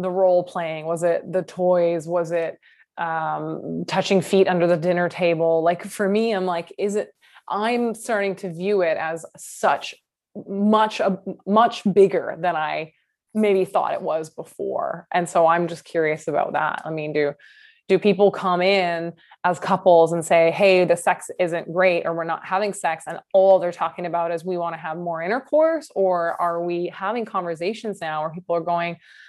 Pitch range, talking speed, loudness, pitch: 170-195 Hz, 190 wpm, -22 LUFS, 180 Hz